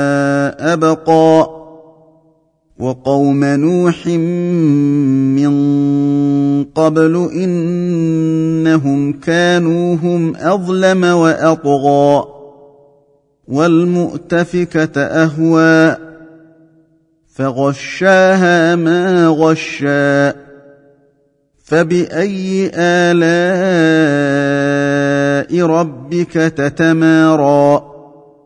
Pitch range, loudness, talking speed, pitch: 140-170 Hz, -12 LUFS, 40 wpm, 160 Hz